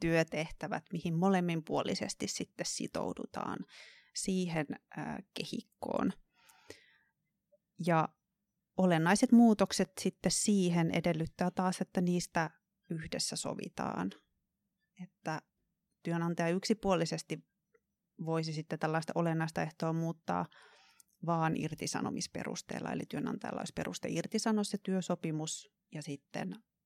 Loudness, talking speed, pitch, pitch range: -35 LUFS, 85 wpm, 180 Hz, 165-200 Hz